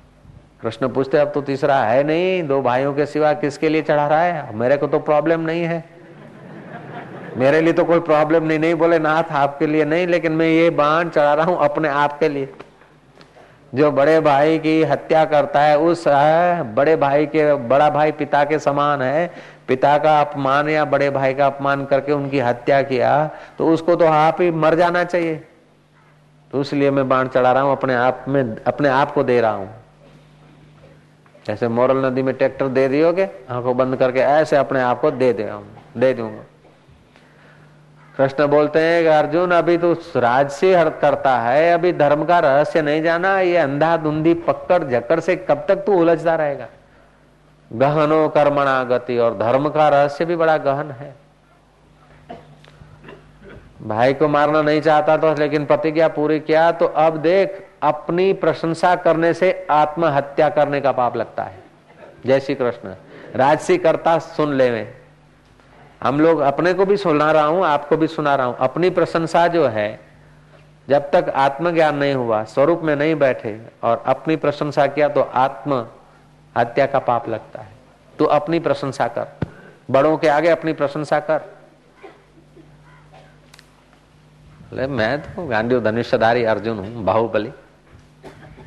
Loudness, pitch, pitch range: -17 LUFS, 150 Hz, 135-160 Hz